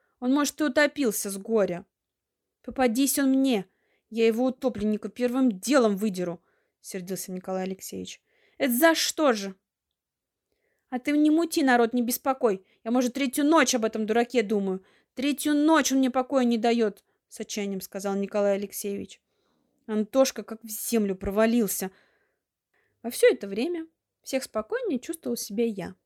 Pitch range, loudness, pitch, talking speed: 205-275 Hz, -26 LUFS, 240 Hz, 145 wpm